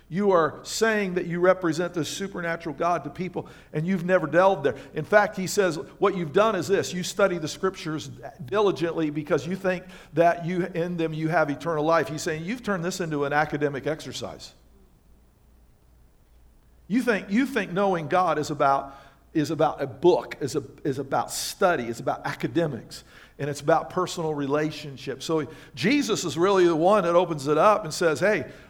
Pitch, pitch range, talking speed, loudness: 165 Hz, 150-185 Hz, 185 wpm, -25 LUFS